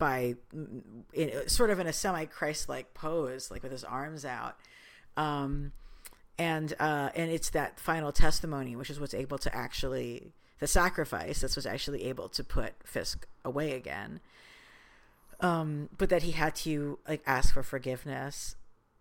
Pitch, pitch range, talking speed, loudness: 145 Hz, 130-160 Hz, 160 wpm, -34 LUFS